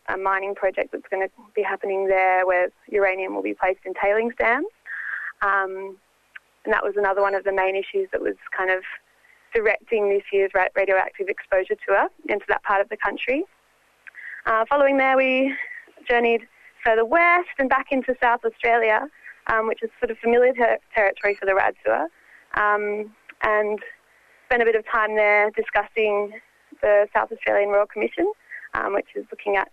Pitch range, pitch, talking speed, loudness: 195-255 Hz, 215 Hz, 175 wpm, -22 LUFS